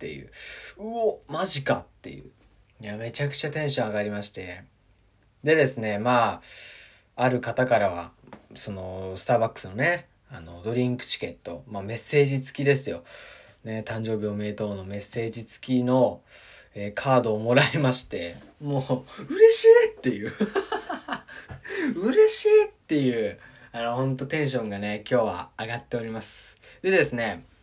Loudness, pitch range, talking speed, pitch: -25 LUFS, 105-140 Hz, 325 characters per minute, 120 Hz